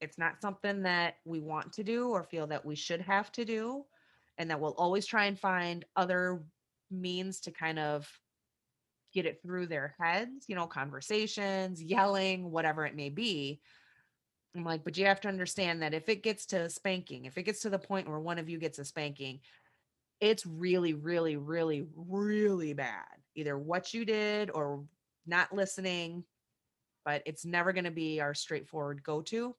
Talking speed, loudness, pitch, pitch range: 185 wpm, -34 LUFS, 175 Hz, 155-195 Hz